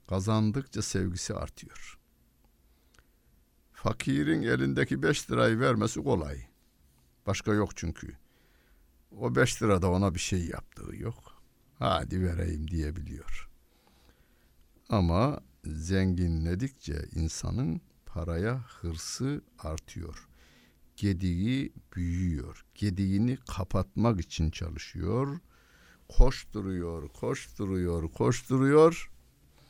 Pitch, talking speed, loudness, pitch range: 90 Hz, 75 wpm, -30 LUFS, 80-110 Hz